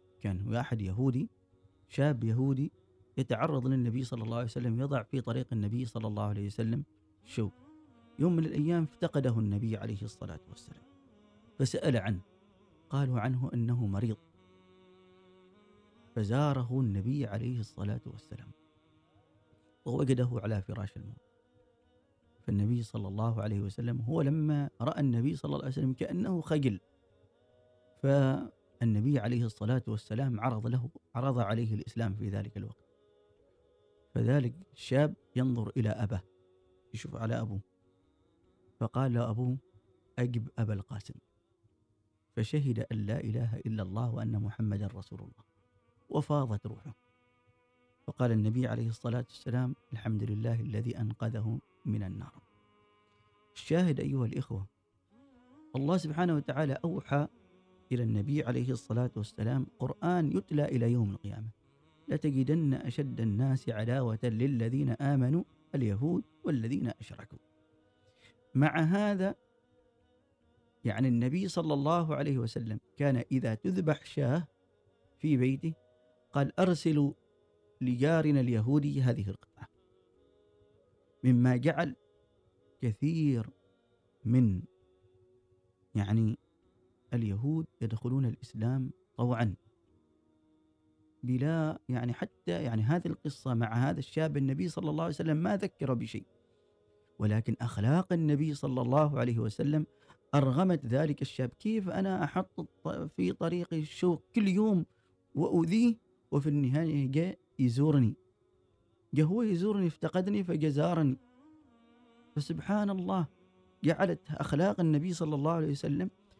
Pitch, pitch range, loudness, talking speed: 125 Hz, 110-150 Hz, -32 LUFS, 110 wpm